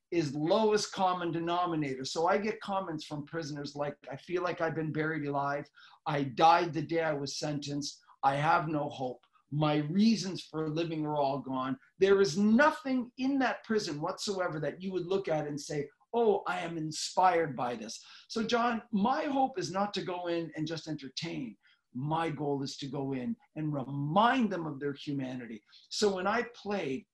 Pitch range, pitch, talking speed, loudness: 145-195 Hz, 165 Hz, 185 wpm, -32 LUFS